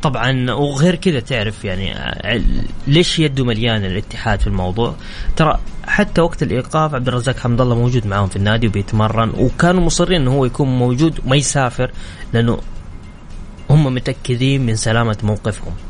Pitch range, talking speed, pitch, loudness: 105-135 Hz, 145 wpm, 120 Hz, -17 LUFS